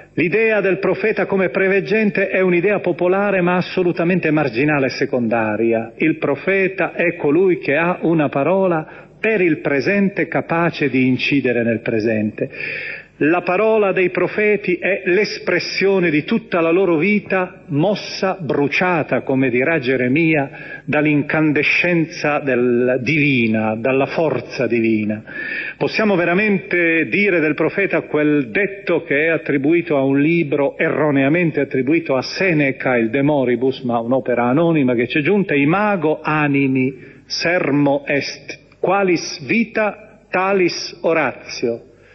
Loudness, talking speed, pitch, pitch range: -17 LUFS, 120 wpm, 160 Hz, 135-185 Hz